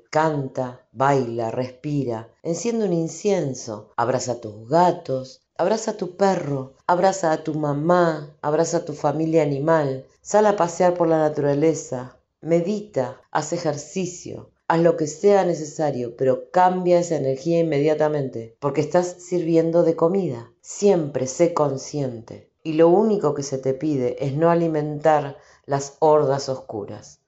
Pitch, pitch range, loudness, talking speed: 155 Hz, 135-170 Hz, -22 LUFS, 140 wpm